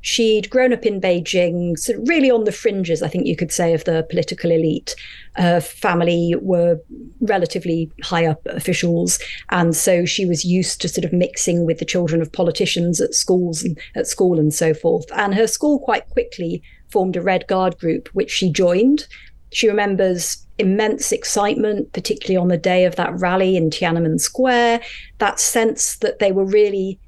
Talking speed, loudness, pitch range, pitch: 180 wpm, -18 LUFS, 170-210 Hz, 185 Hz